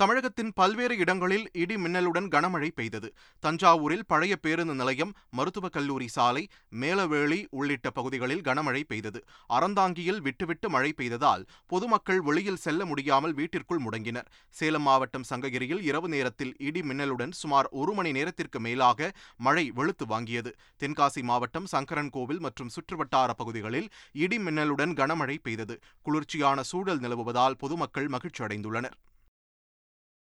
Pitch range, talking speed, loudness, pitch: 130-175 Hz, 120 wpm, -29 LUFS, 145 Hz